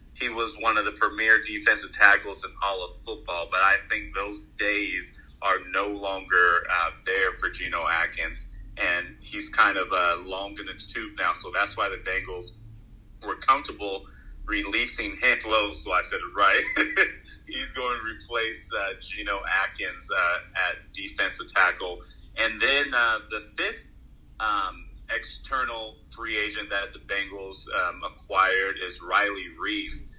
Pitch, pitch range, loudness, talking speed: 100 Hz, 95-110 Hz, -25 LUFS, 155 wpm